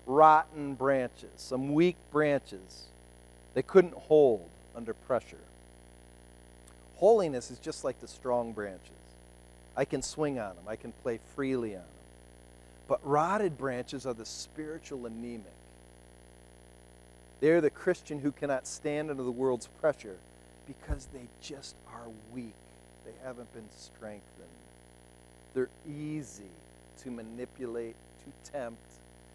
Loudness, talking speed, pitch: -31 LUFS, 125 wpm, 100 Hz